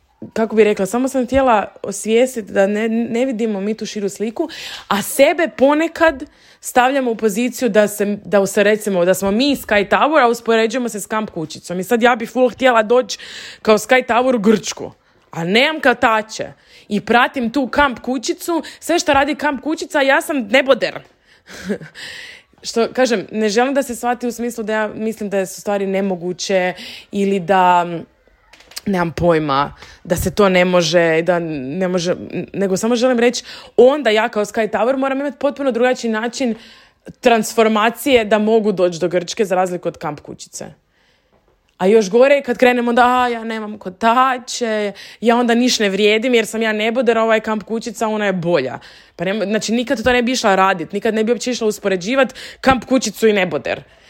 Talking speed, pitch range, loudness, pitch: 175 wpm, 200-255 Hz, -16 LUFS, 225 Hz